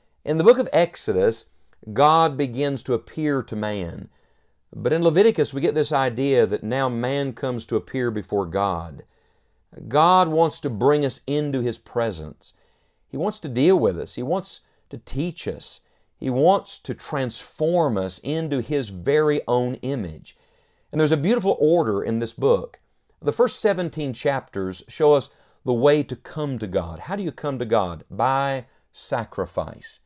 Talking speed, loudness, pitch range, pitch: 165 wpm, -22 LUFS, 120-155 Hz, 140 Hz